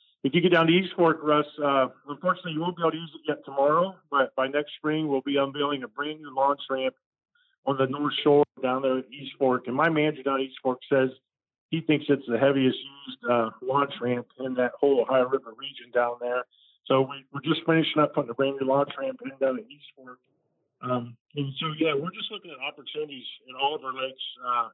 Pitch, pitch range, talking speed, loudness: 140 Hz, 130-155 Hz, 235 wpm, -26 LUFS